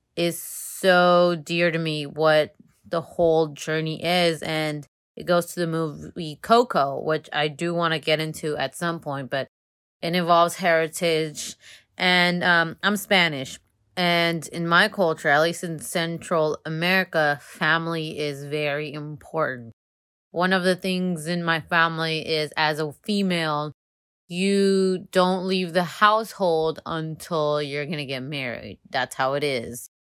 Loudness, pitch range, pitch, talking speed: -23 LUFS, 150-175 Hz, 160 Hz, 145 wpm